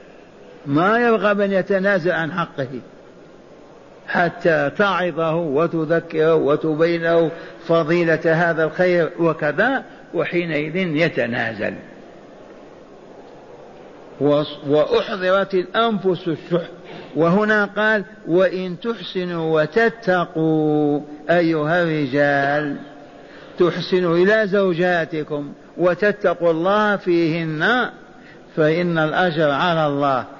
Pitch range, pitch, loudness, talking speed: 155-185 Hz, 170 Hz, -19 LUFS, 70 wpm